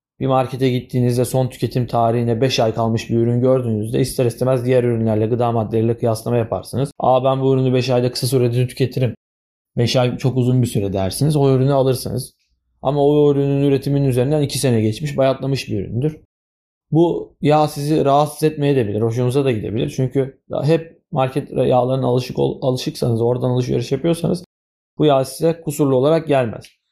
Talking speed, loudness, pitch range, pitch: 165 wpm, -18 LUFS, 115-140 Hz, 130 Hz